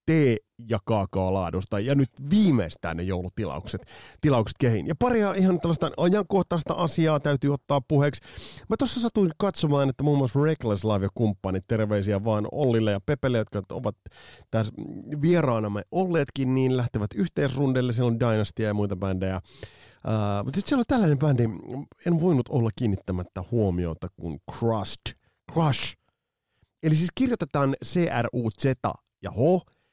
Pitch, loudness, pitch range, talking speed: 125 Hz, -26 LUFS, 105-155 Hz, 140 wpm